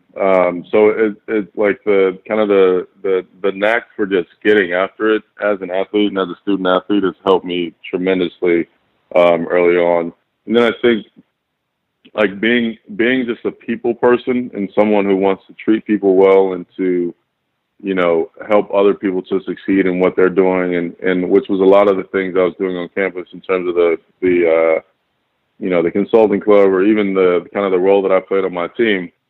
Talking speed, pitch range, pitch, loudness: 210 wpm, 90-105 Hz, 95 Hz, -15 LUFS